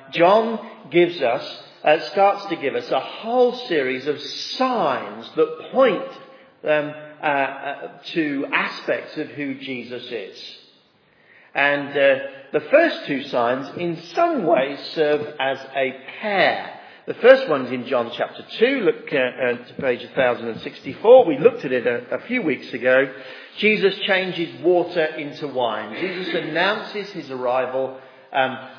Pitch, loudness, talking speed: 170 Hz, -21 LUFS, 155 wpm